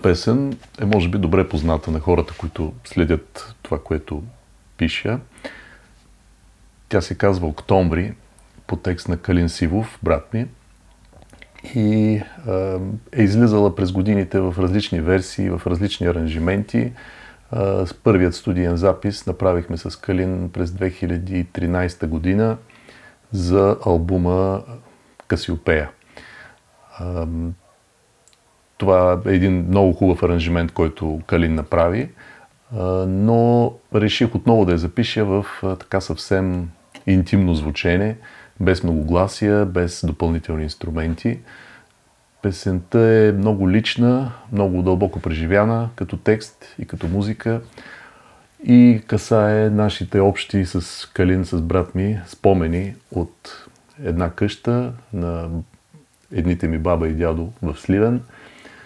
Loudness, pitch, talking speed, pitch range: -20 LUFS, 95 Hz, 110 wpm, 85-105 Hz